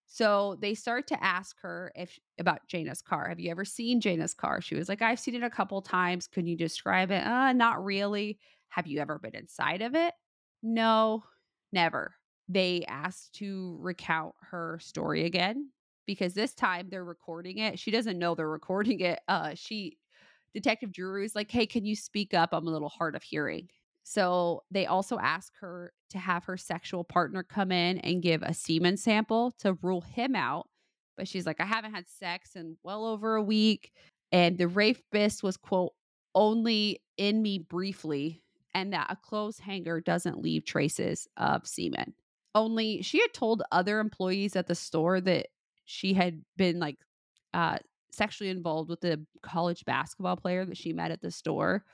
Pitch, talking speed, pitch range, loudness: 190 Hz, 180 wpm, 175-215 Hz, -31 LUFS